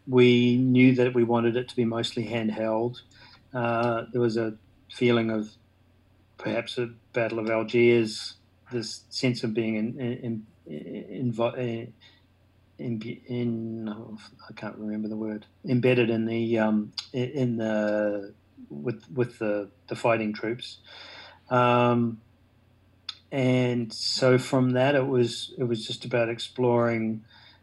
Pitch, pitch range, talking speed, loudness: 115 Hz, 110-120 Hz, 140 wpm, -26 LUFS